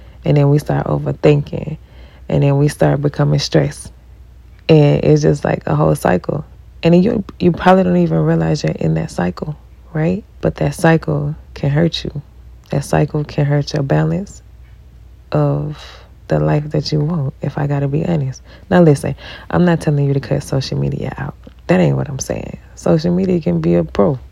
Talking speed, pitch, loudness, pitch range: 190 wpm, 145 Hz, -16 LUFS, 130-165 Hz